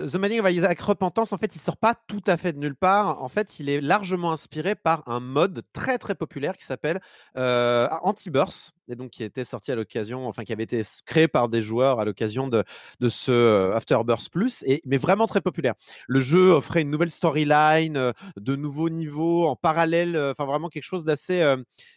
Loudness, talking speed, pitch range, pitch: -24 LUFS, 210 wpm, 125-180 Hz, 155 Hz